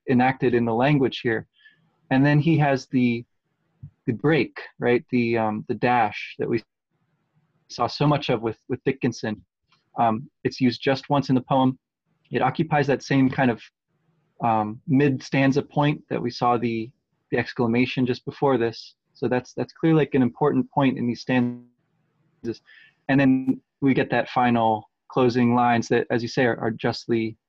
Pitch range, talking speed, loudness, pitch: 120-140 Hz, 170 wpm, -23 LUFS, 130 Hz